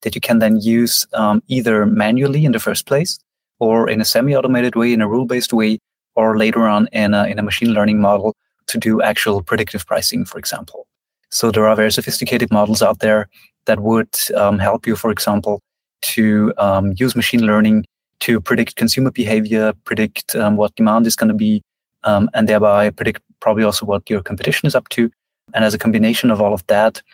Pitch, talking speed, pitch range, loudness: 110 Hz, 205 wpm, 105-115 Hz, -16 LUFS